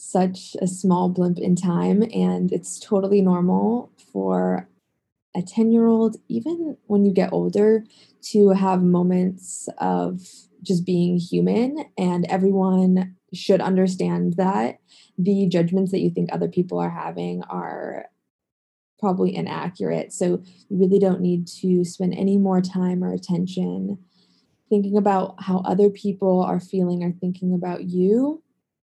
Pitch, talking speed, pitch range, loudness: 185 Hz, 140 wpm, 175-200 Hz, -22 LUFS